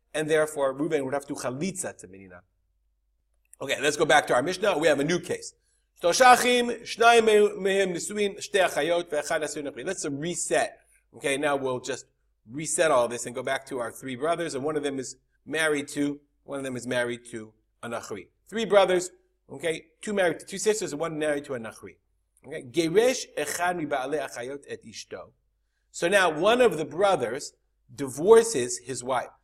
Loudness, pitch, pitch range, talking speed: -25 LUFS, 155 Hz, 135-200 Hz, 150 wpm